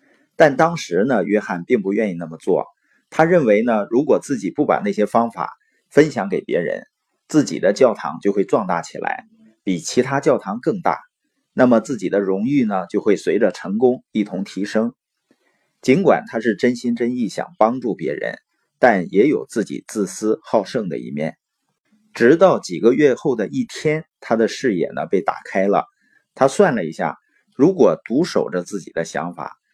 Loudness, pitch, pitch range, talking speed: -19 LUFS, 110 Hz, 95-130 Hz, 255 characters per minute